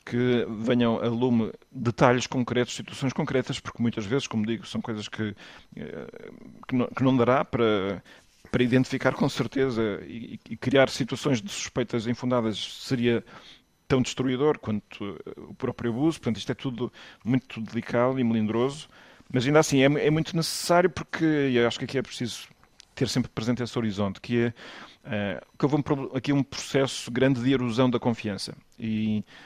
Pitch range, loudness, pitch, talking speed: 115-135 Hz, -26 LUFS, 125 Hz, 170 wpm